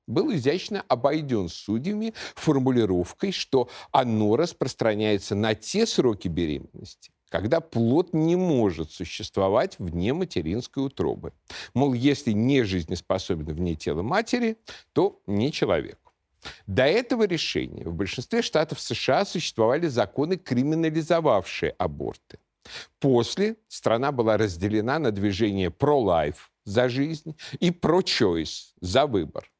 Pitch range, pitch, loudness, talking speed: 105-170 Hz, 130 Hz, -25 LUFS, 110 wpm